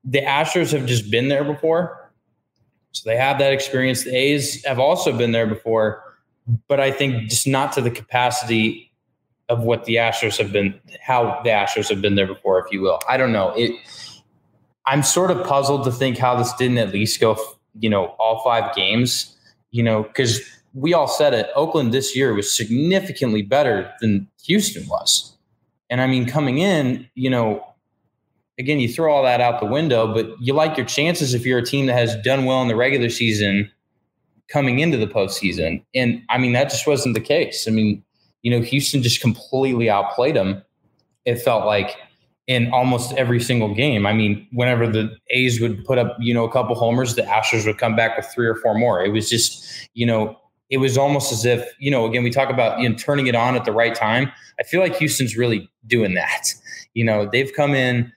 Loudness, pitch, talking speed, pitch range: -19 LUFS, 125 Hz, 205 wpm, 115-135 Hz